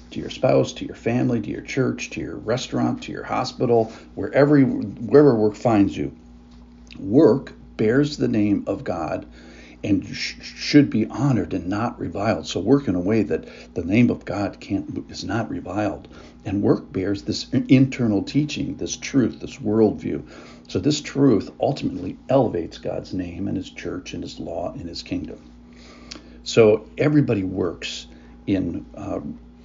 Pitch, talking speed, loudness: 100 Hz, 160 wpm, -22 LUFS